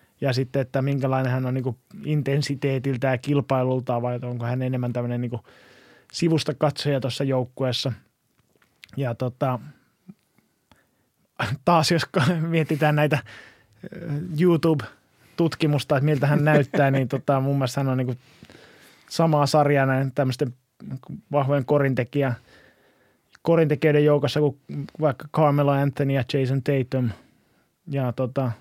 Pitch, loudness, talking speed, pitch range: 140 Hz, -23 LUFS, 115 wpm, 130-150 Hz